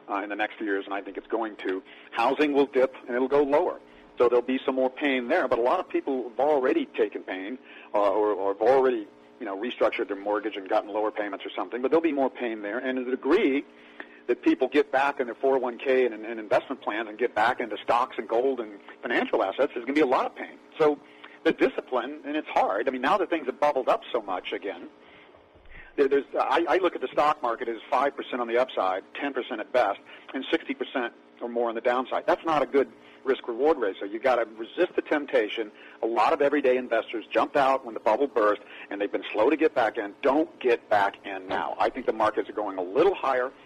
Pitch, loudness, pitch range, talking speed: 125 Hz, -26 LUFS, 105-140 Hz, 240 wpm